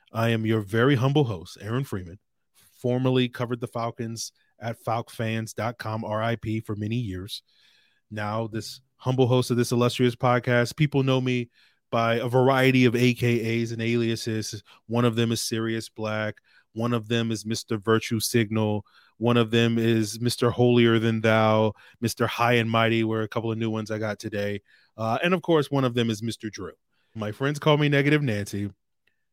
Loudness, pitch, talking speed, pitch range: -25 LUFS, 115 Hz, 175 wpm, 110-125 Hz